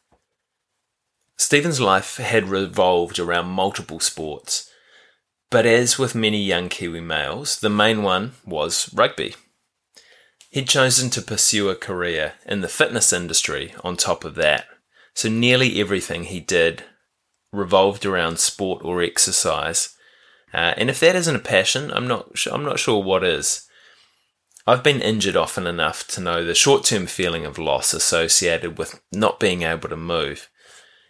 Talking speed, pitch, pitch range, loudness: 150 wpm, 105 Hz, 90-125 Hz, -19 LUFS